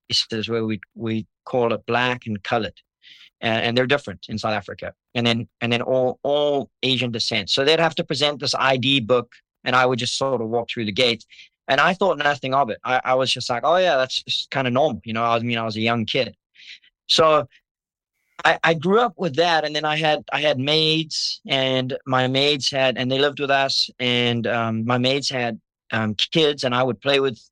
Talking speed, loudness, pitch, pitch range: 225 wpm, -21 LUFS, 130 Hz, 115-145 Hz